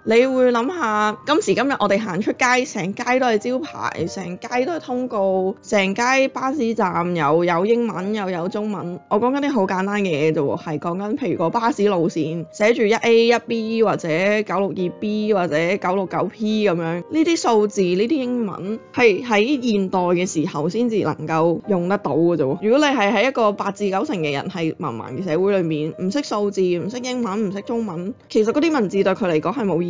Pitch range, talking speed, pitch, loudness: 175-230 Hz, 305 characters per minute, 205 Hz, -20 LUFS